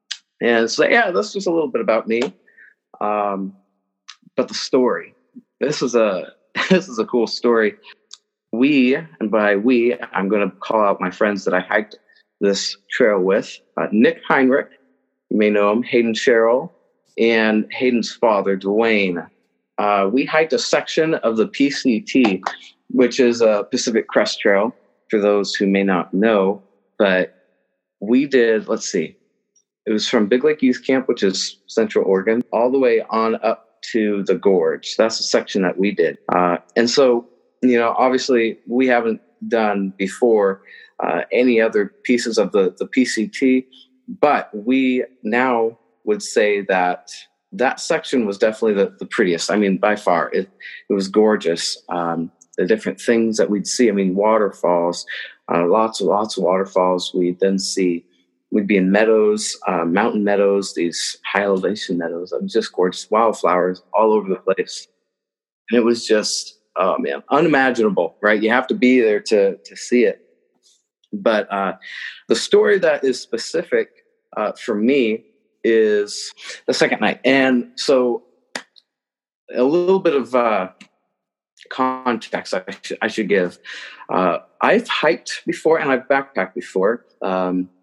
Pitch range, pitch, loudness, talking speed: 100-130 Hz, 110 Hz, -18 LUFS, 160 wpm